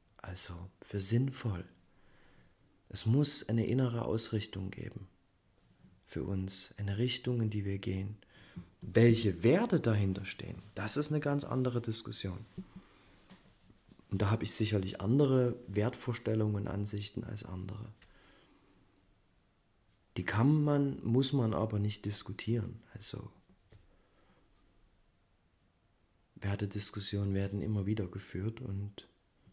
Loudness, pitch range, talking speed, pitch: -34 LUFS, 95-115 Hz, 110 wpm, 105 Hz